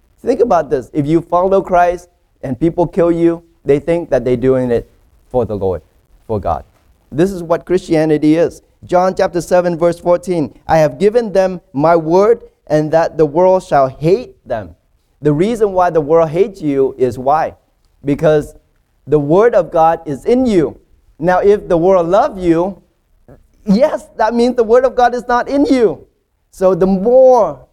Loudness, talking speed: -13 LUFS, 175 wpm